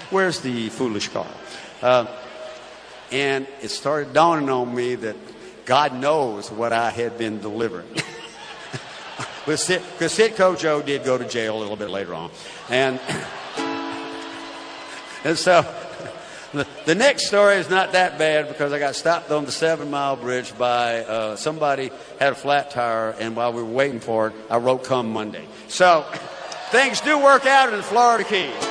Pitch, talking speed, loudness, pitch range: 135 Hz, 165 wpm, -21 LUFS, 115-160 Hz